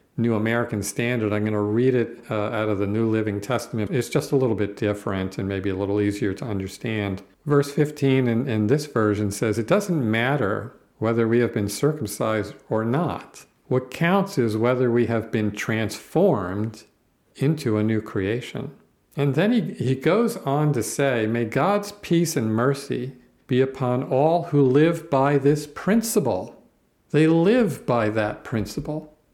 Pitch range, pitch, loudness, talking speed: 110-145 Hz, 120 Hz, -23 LUFS, 170 wpm